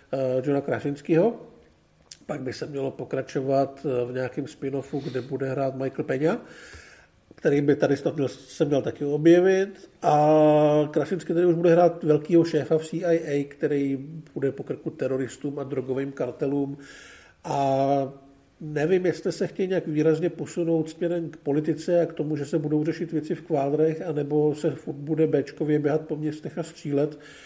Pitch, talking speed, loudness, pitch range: 150 Hz, 155 wpm, -25 LUFS, 140-160 Hz